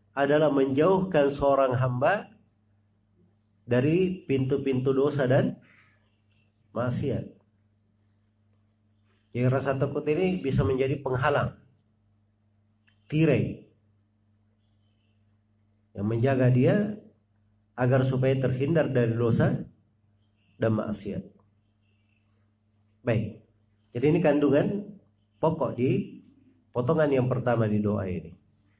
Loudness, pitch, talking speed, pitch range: -26 LUFS, 105 Hz, 80 wpm, 105-135 Hz